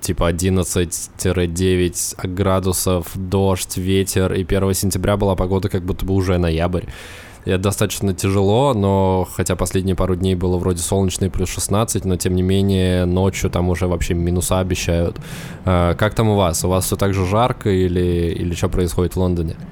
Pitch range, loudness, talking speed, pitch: 90-95 Hz, -18 LUFS, 170 wpm, 95 Hz